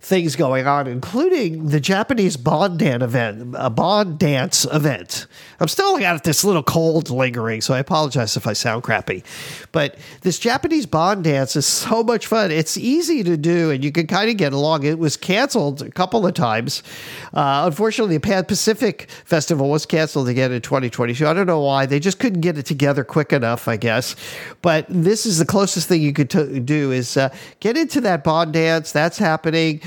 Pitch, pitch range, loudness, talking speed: 160 Hz, 140-190 Hz, -18 LUFS, 200 wpm